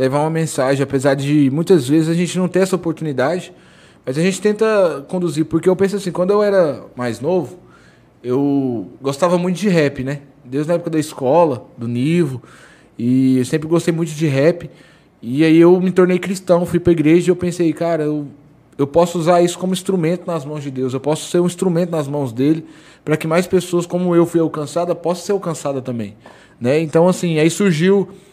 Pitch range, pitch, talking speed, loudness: 145-175 Hz, 165 Hz, 205 wpm, -17 LUFS